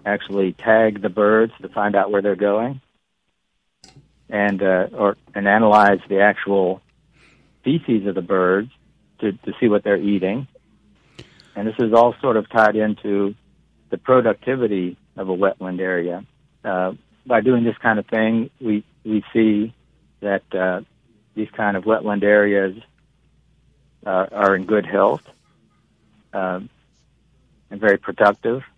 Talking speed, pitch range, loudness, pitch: 140 wpm, 100-110 Hz, -19 LUFS, 105 Hz